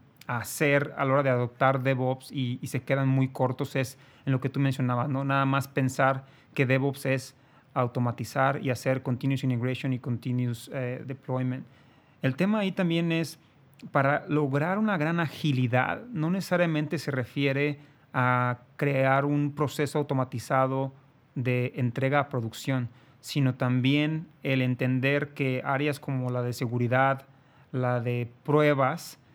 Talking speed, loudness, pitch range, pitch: 145 wpm, -28 LUFS, 130-145 Hz, 135 Hz